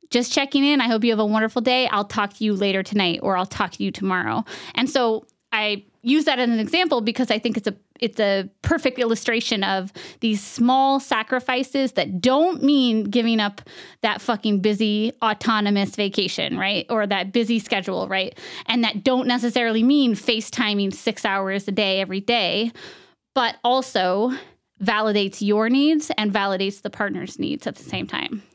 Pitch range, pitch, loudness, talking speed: 205-250 Hz, 225 Hz, -21 LUFS, 180 wpm